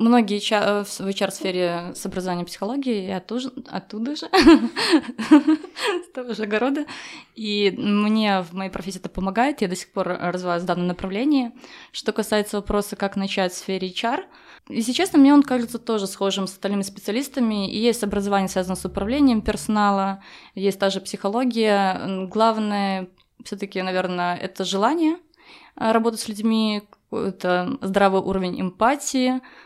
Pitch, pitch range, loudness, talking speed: 205 Hz, 190-240 Hz, -22 LUFS, 150 wpm